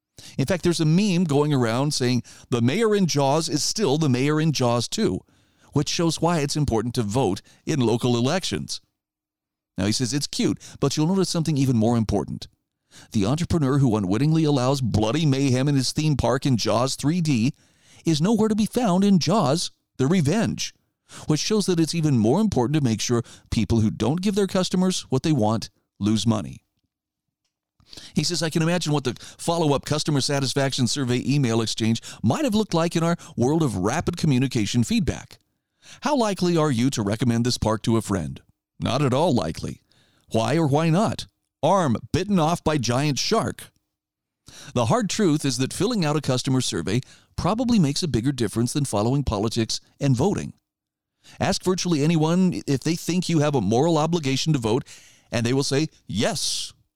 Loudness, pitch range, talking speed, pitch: -23 LUFS, 120-165 Hz, 180 wpm, 140 Hz